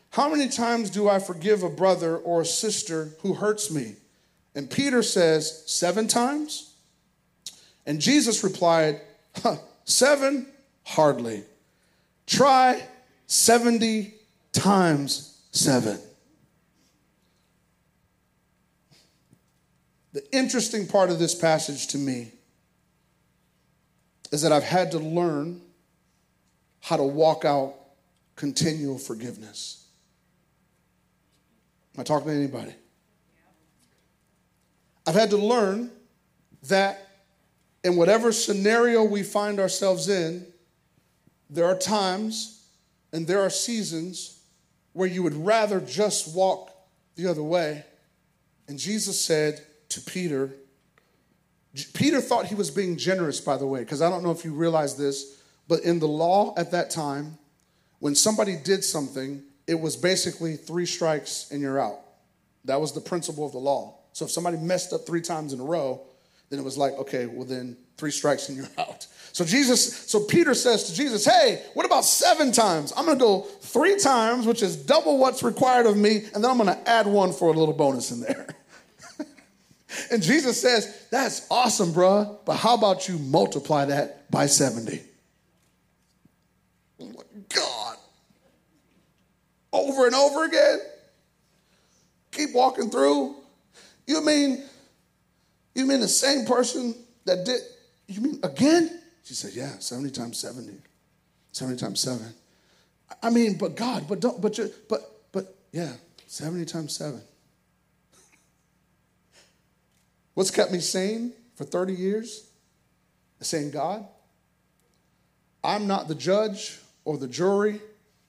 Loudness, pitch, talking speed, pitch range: -24 LUFS, 180 Hz, 130 wpm, 150-220 Hz